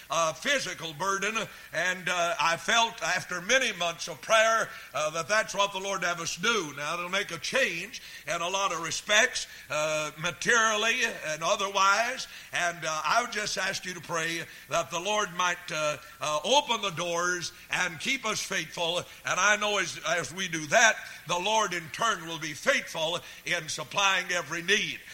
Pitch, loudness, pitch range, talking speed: 180 Hz, -27 LUFS, 165-210 Hz, 180 wpm